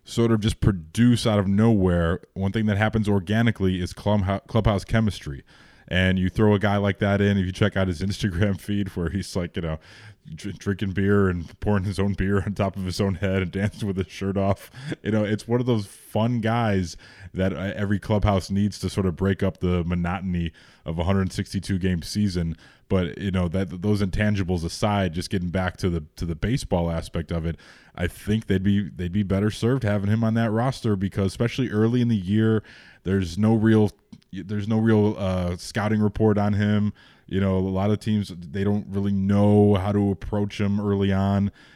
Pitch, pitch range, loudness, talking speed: 100 Hz, 95-105 Hz, -24 LUFS, 205 wpm